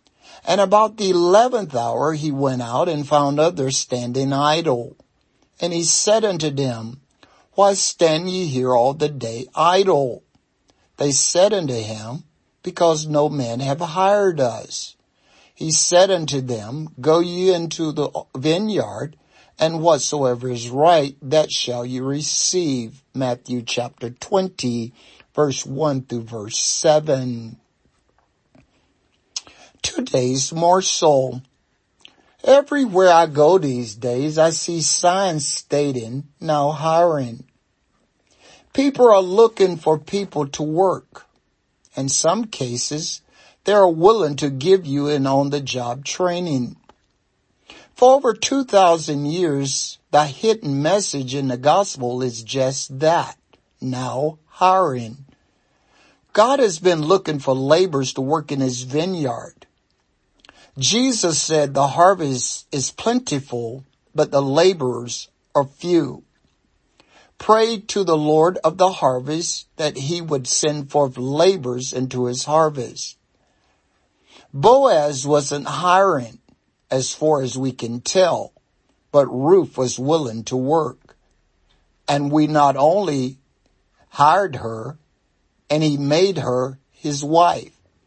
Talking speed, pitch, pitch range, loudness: 120 wpm, 145 Hz, 130-170 Hz, -19 LUFS